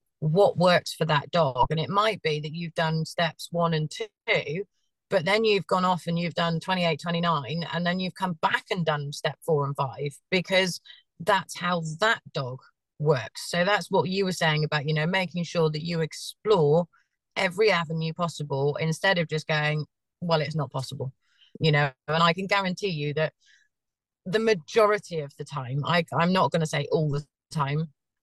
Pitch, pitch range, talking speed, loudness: 165 Hz, 150-185 Hz, 190 wpm, -26 LUFS